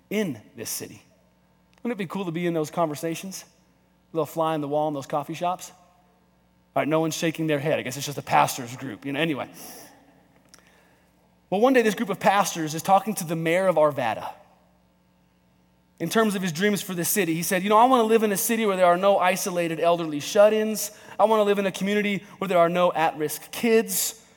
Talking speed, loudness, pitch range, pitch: 225 wpm, -24 LUFS, 150-200 Hz, 170 Hz